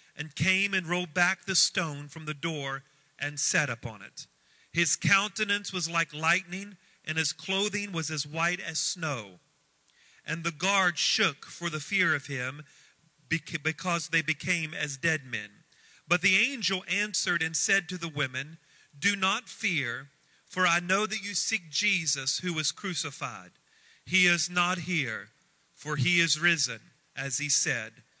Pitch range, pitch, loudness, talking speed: 150-190 Hz, 170 Hz, -28 LUFS, 160 wpm